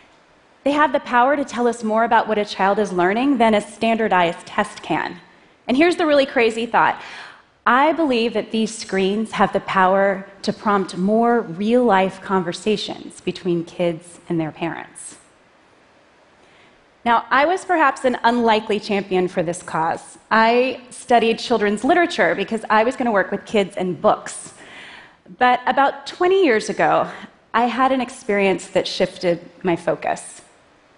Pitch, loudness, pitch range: 215 Hz, -19 LUFS, 190-240 Hz